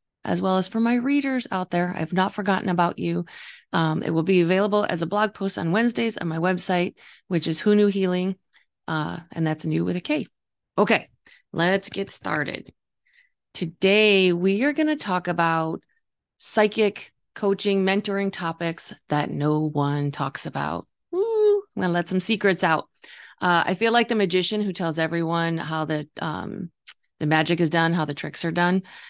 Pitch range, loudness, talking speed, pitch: 165-205 Hz, -23 LUFS, 185 wpm, 185 Hz